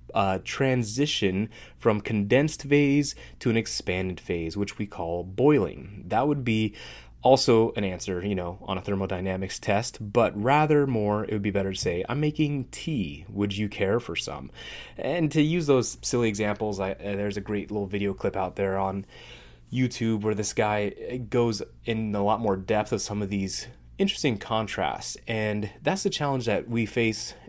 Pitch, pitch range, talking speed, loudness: 105 Hz, 100-125 Hz, 180 wpm, -27 LUFS